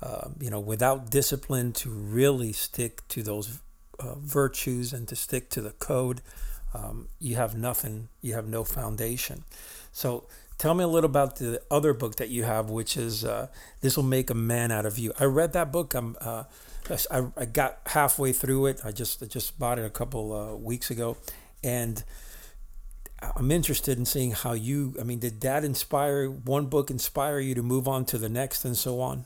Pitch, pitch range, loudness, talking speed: 125 Hz, 115-135 Hz, -28 LUFS, 200 wpm